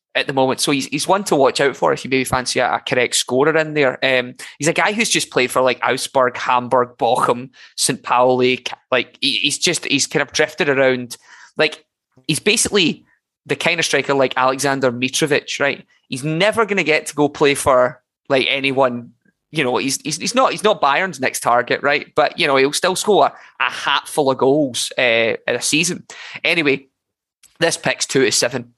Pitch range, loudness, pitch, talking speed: 130-160 Hz, -17 LUFS, 140 Hz, 205 wpm